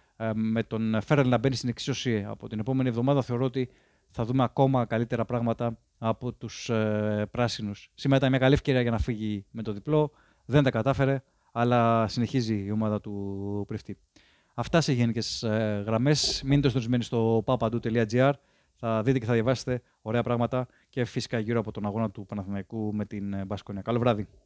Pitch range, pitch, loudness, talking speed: 110-130 Hz, 115 Hz, -28 LUFS, 165 wpm